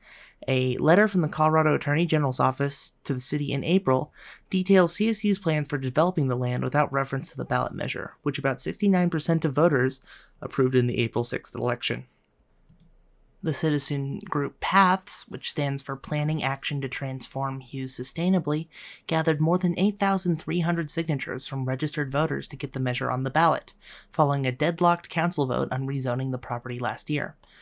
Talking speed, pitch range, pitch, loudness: 165 wpm, 135-165 Hz, 145 Hz, -26 LUFS